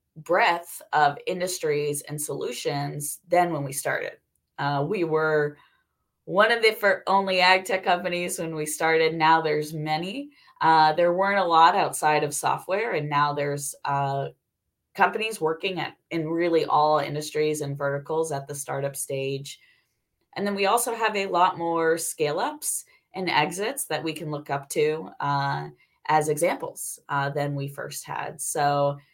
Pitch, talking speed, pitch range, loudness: 155 Hz, 160 wpm, 145-175 Hz, -25 LUFS